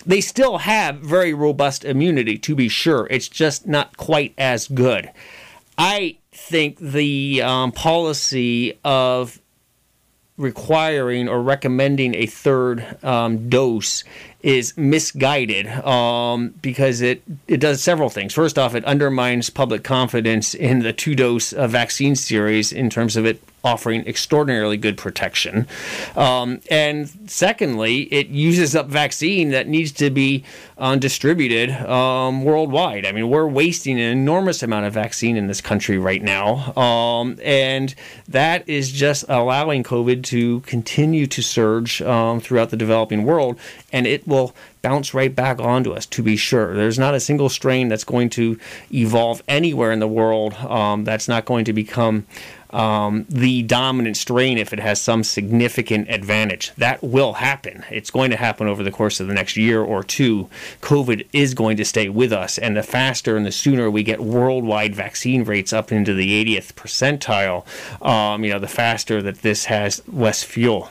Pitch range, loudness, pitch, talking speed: 110-140 Hz, -19 LUFS, 125 Hz, 160 wpm